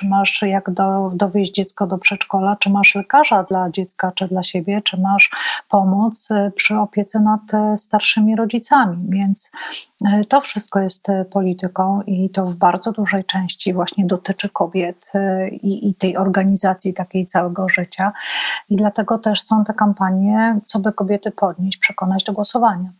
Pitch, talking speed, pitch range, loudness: 200 Hz, 150 wpm, 190-210 Hz, -17 LUFS